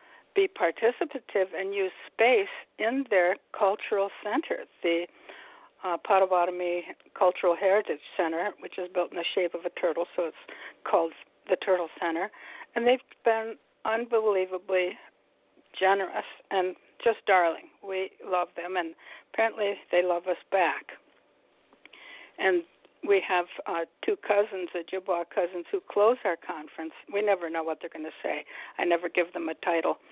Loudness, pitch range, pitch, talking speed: -28 LUFS, 175-225 Hz, 190 Hz, 145 wpm